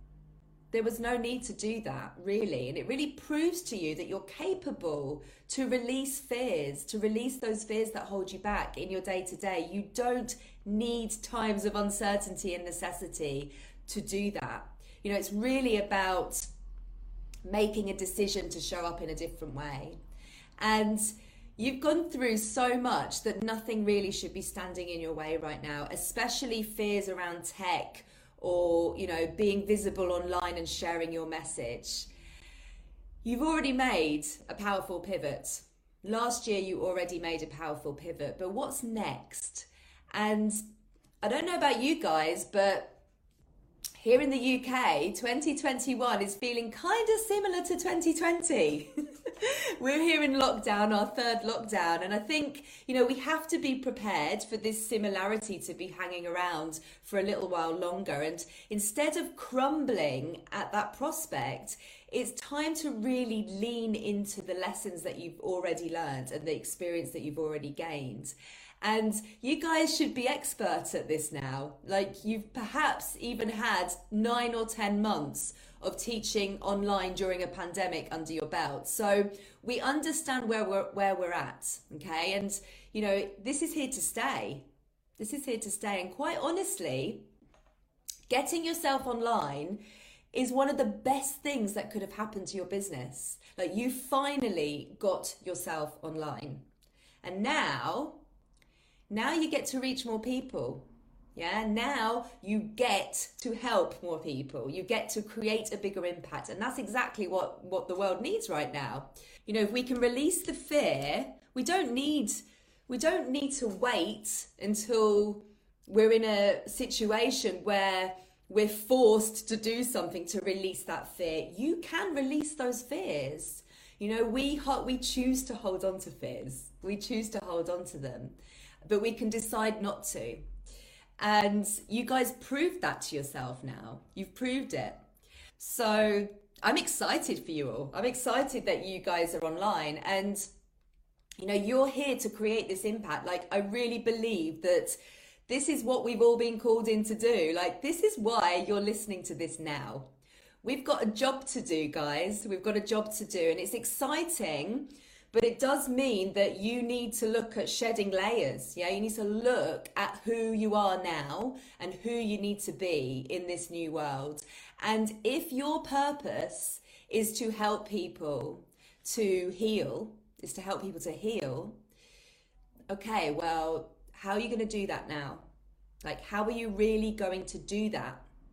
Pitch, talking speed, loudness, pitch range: 215 Hz, 165 wpm, -32 LUFS, 180-250 Hz